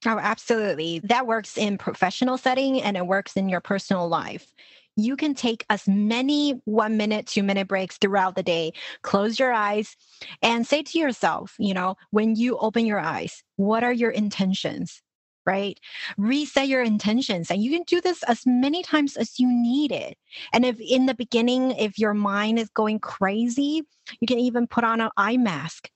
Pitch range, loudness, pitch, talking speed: 200-250 Hz, -23 LUFS, 220 Hz, 185 wpm